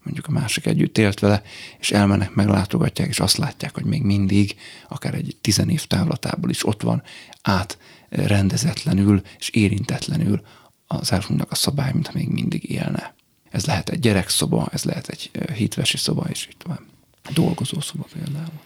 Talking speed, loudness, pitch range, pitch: 160 wpm, -21 LUFS, 100-155 Hz, 105 Hz